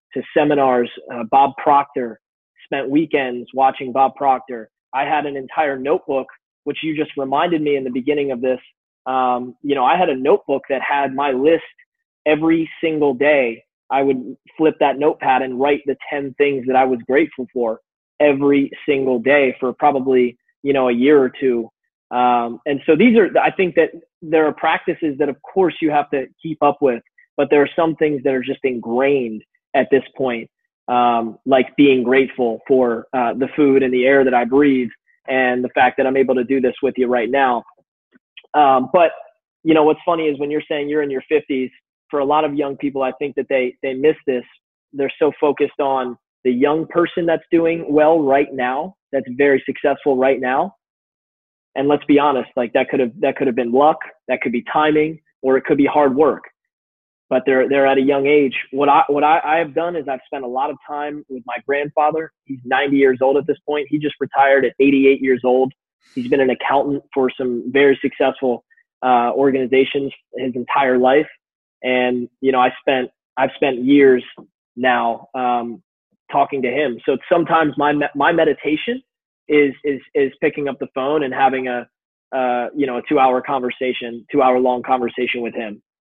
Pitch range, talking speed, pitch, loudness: 130-150 Hz, 195 wpm, 135 Hz, -17 LUFS